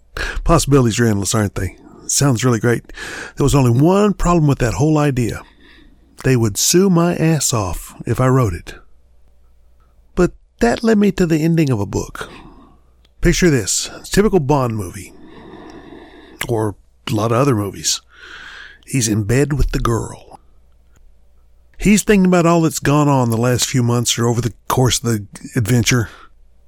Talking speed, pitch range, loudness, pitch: 165 wpm, 100-160 Hz, -16 LUFS, 125 Hz